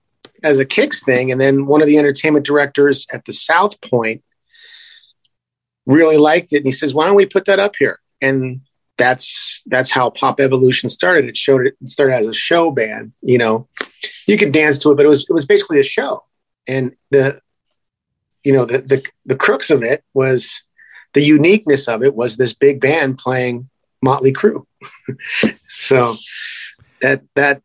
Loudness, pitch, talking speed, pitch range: -14 LUFS, 140 Hz, 180 wpm, 130-155 Hz